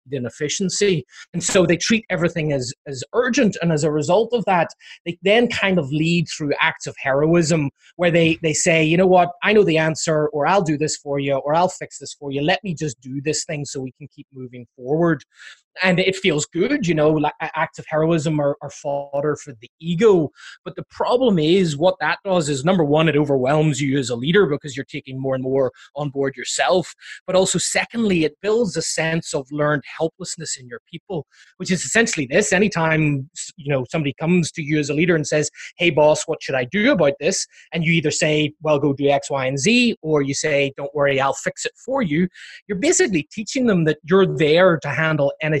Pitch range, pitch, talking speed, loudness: 145-180 Hz, 155 Hz, 220 wpm, -19 LUFS